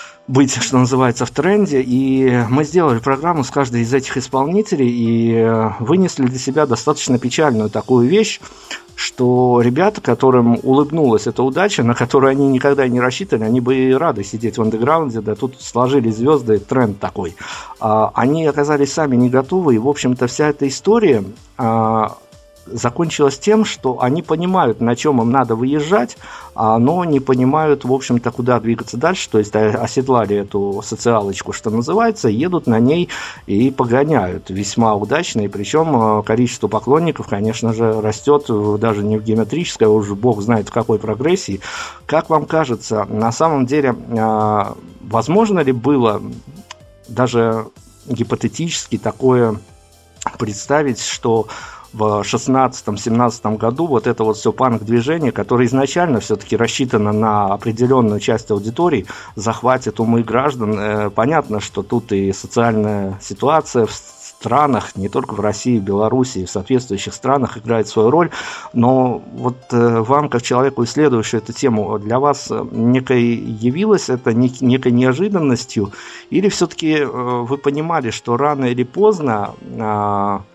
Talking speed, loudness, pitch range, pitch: 135 wpm, -16 LUFS, 110-140 Hz, 120 Hz